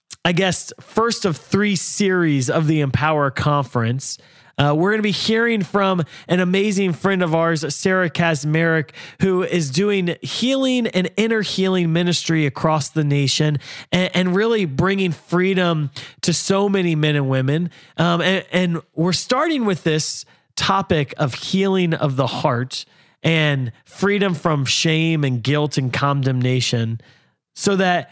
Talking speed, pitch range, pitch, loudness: 145 wpm, 145-190 Hz, 165 Hz, -19 LUFS